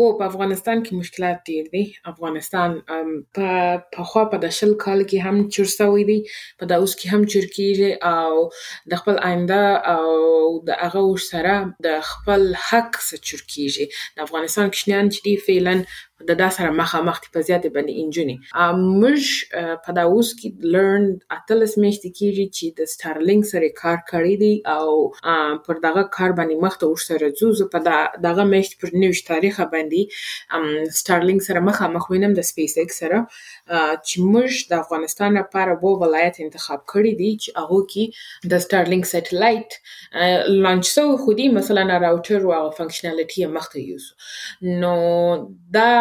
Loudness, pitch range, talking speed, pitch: -19 LUFS, 165-200 Hz, 155 wpm, 180 Hz